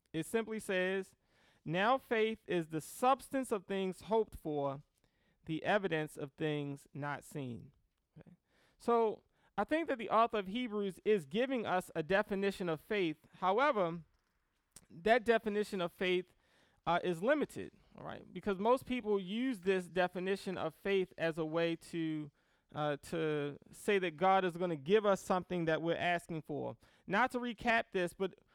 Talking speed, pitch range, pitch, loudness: 160 wpm, 165-215 Hz, 185 Hz, -36 LUFS